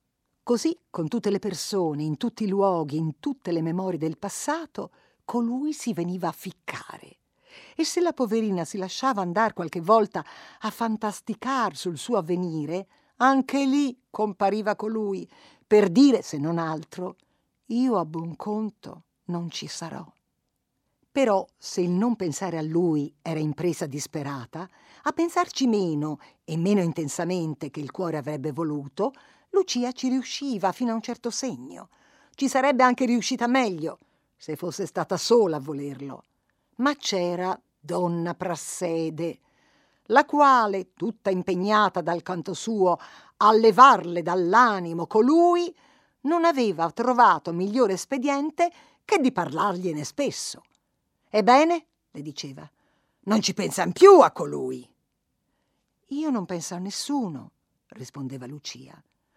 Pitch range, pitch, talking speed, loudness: 170-255 Hz, 195 Hz, 130 wpm, -24 LUFS